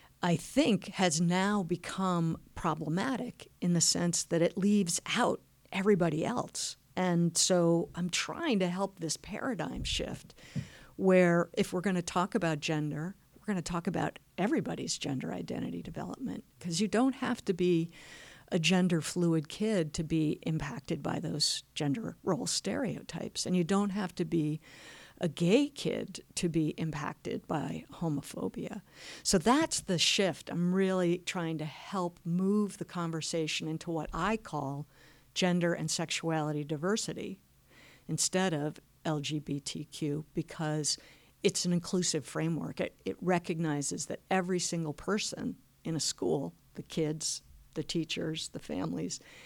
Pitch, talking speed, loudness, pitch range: 170 Hz, 140 wpm, -32 LUFS, 155-185 Hz